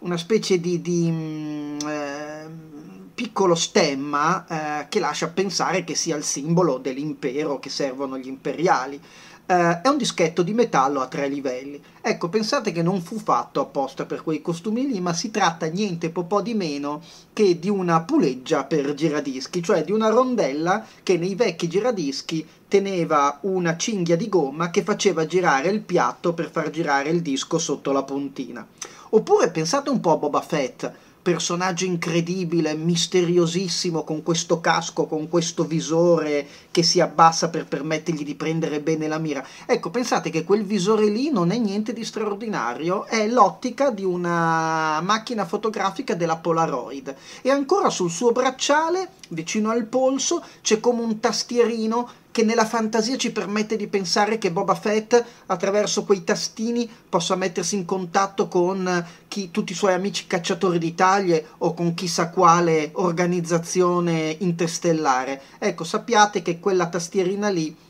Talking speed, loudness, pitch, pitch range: 155 wpm, -22 LUFS, 180 Hz, 160-210 Hz